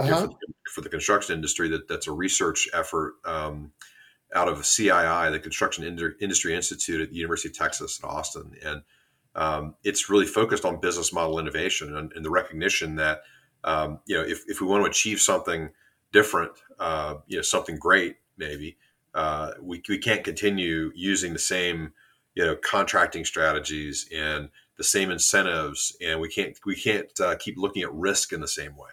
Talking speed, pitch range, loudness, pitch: 180 wpm, 75-80 Hz, -25 LUFS, 80 Hz